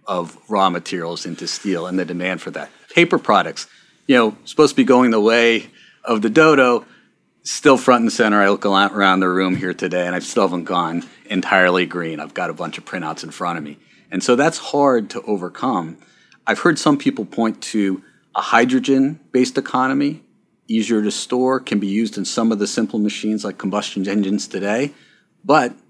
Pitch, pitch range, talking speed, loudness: 105 Hz, 95-125 Hz, 195 wpm, -18 LUFS